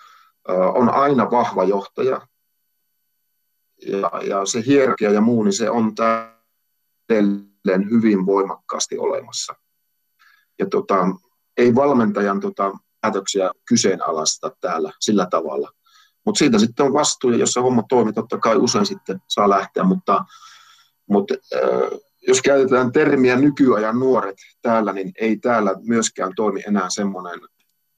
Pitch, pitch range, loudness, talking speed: 115 Hz, 100-155 Hz, -19 LUFS, 125 wpm